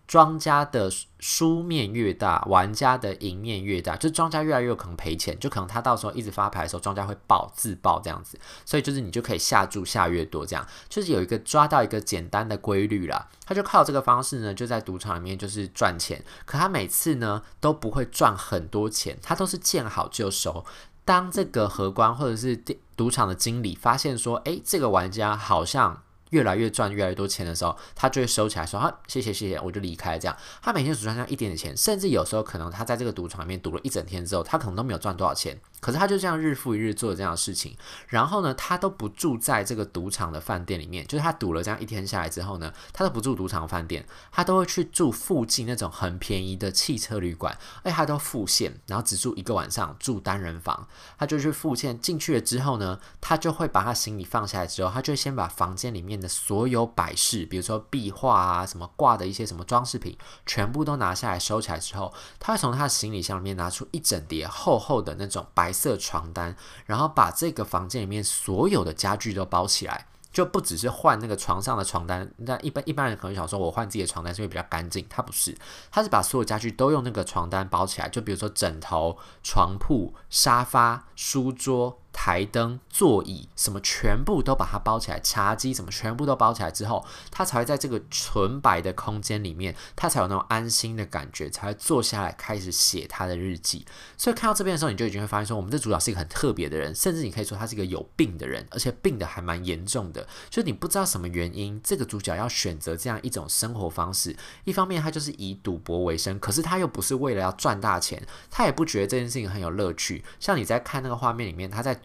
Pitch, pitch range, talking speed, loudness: 105 Hz, 95-125 Hz, 355 characters per minute, -26 LUFS